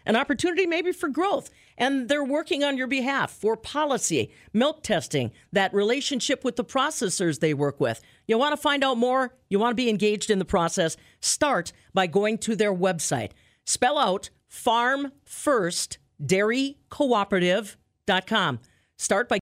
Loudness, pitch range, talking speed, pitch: -25 LUFS, 185-275 Hz, 150 wpm, 225 Hz